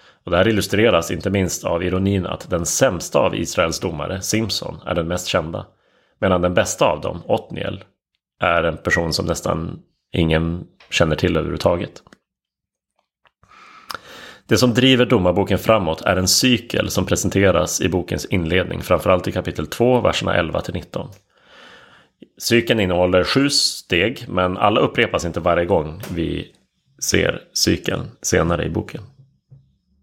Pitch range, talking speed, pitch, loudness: 90-115 Hz, 140 wpm, 95 Hz, -19 LUFS